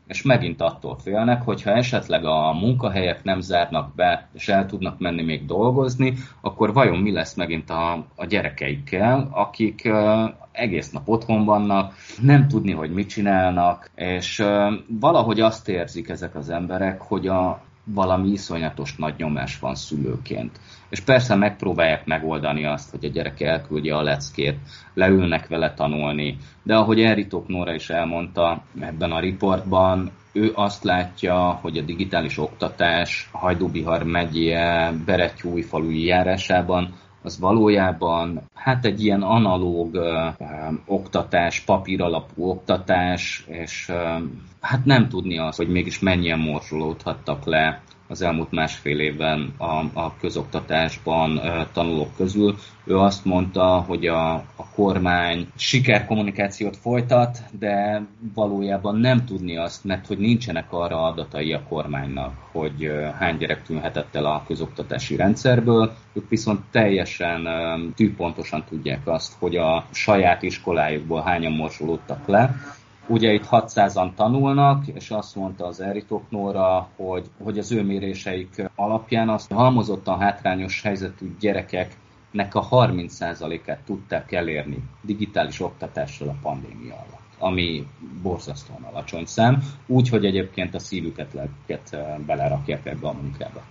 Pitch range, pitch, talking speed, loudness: 80-105 Hz, 95 Hz, 125 wpm, -22 LUFS